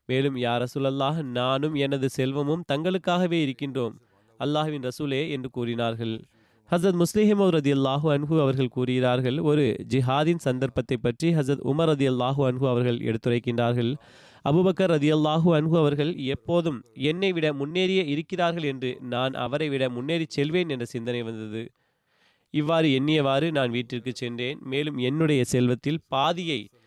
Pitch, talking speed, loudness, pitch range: 135 Hz, 130 wpm, -25 LUFS, 125-155 Hz